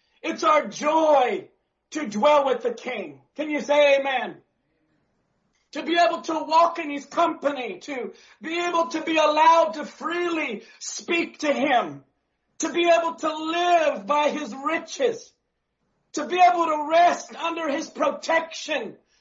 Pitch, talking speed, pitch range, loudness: 315 Hz, 145 wpm, 290-335 Hz, -23 LUFS